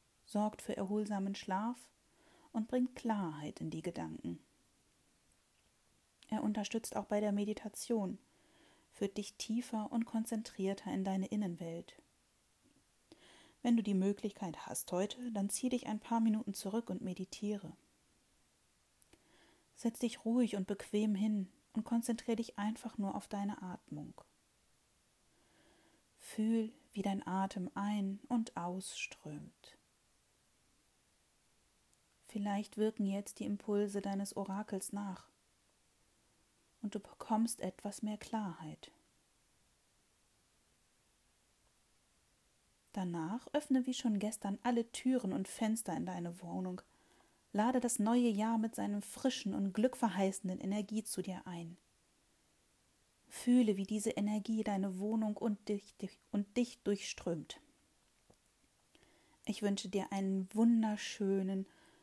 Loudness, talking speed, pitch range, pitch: -38 LUFS, 110 wpm, 195-230 Hz, 210 Hz